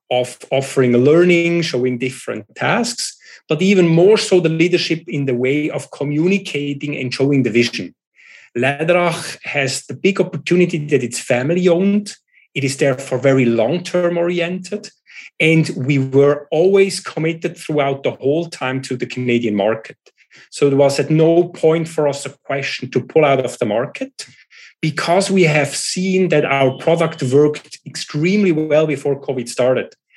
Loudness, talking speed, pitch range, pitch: -16 LUFS, 155 wpm, 135-170 Hz, 150 Hz